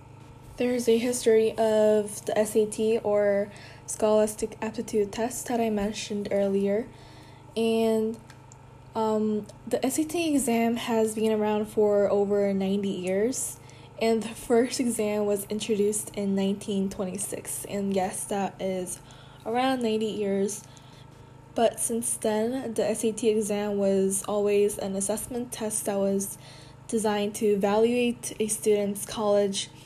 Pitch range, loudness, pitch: 195-225 Hz, -27 LUFS, 210 Hz